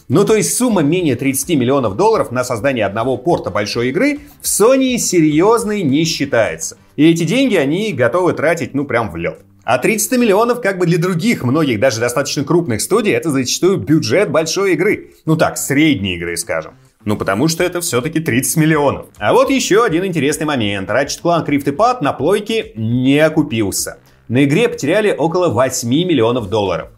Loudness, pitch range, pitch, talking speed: -15 LUFS, 125-185 Hz, 155 Hz, 175 wpm